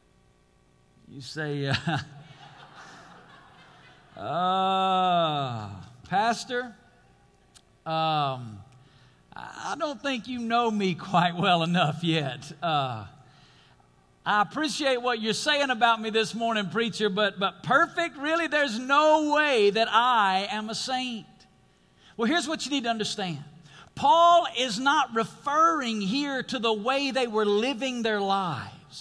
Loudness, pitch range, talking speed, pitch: -25 LUFS, 150-255 Hz, 120 wpm, 210 Hz